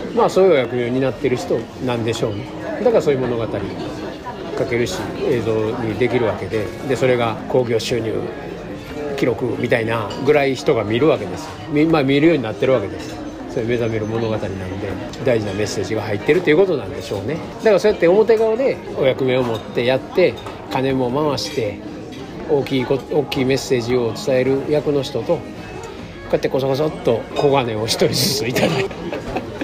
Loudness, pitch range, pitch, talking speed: -19 LUFS, 110-140 Hz, 130 Hz, 385 characters per minute